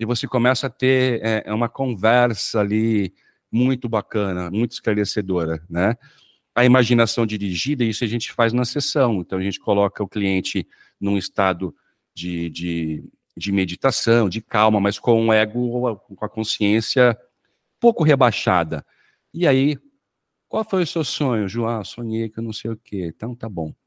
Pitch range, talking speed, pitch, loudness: 100-125 Hz, 160 wpm, 115 Hz, -21 LUFS